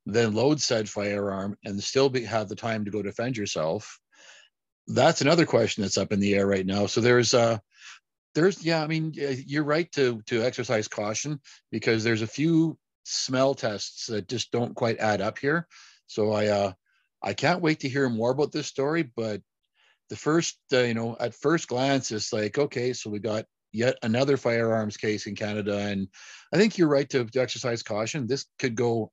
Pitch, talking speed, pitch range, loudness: 120 Hz, 200 wpm, 105-140 Hz, -26 LUFS